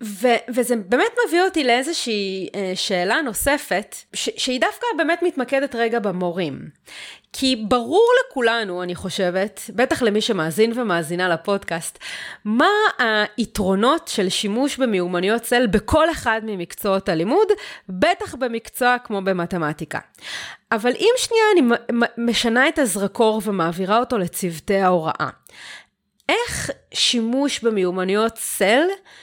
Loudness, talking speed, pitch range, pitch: -20 LUFS, 110 wpm, 195-275 Hz, 230 Hz